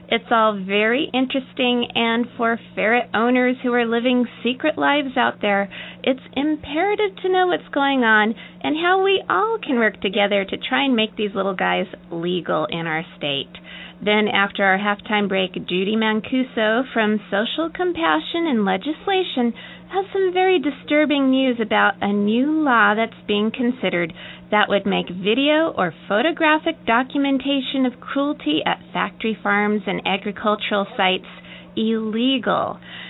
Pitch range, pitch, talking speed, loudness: 205-275 Hz, 230 Hz, 145 wpm, -20 LUFS